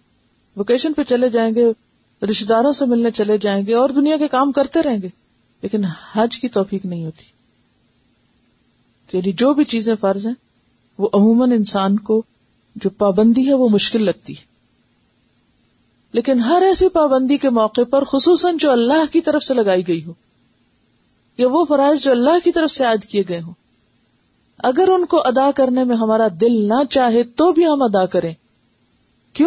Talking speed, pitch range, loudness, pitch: 175 wpm, 200-275 Hz, -16 LUFS, 235 Hz